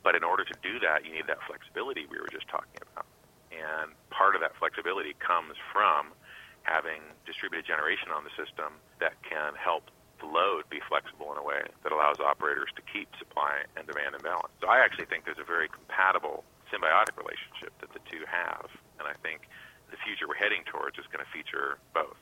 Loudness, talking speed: -31 LUFS, 205 wpm